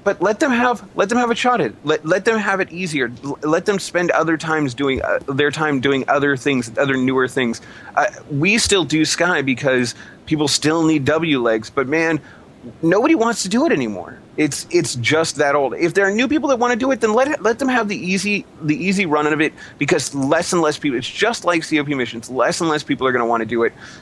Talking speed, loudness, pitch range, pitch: 250 wpm, -18 LUFS, 140-195 Hz, 155 Hz